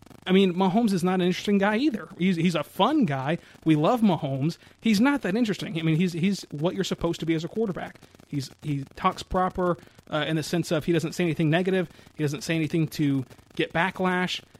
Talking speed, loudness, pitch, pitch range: 220 wpm, -25 LUFS, 170 Hz, 155-190 Hz